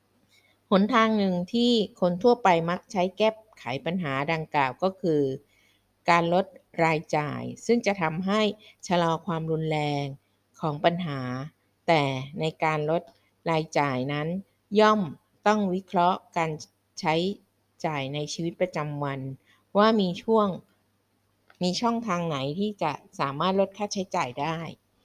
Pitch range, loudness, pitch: 145-190 Hz, -26 LUFS, 165 Hz